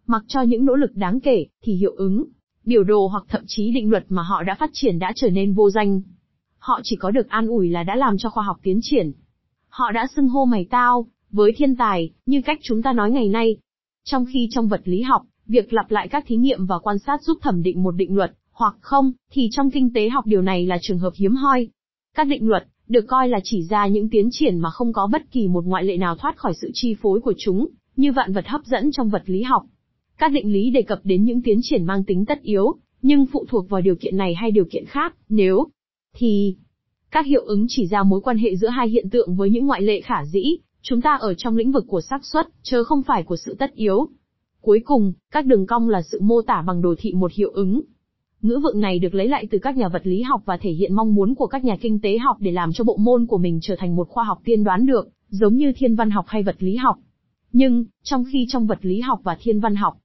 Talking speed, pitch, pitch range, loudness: 260 wpm, 220 Hz, 195-255 Hz, -20 LUFS